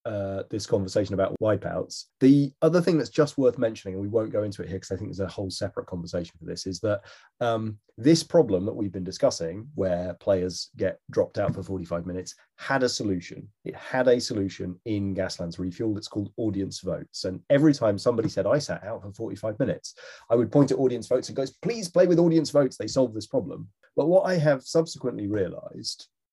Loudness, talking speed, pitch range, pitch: -26 LUFS, 215 wpm, 95-135 Hz, 110 Hz